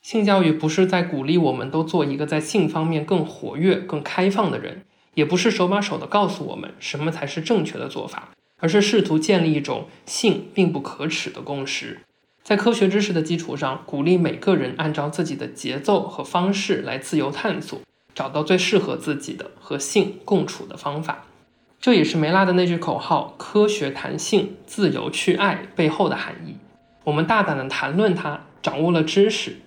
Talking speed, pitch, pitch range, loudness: 285 characters per minute, 175 Hz, 155-200 Hz, -22 LUFS